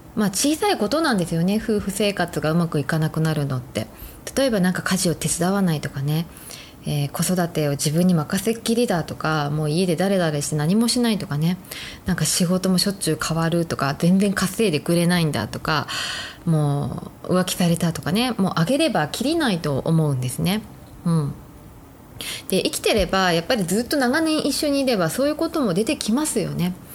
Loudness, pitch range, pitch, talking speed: -21 LUFS, 155-215 Hz, 180 Hz, 385 characters per minute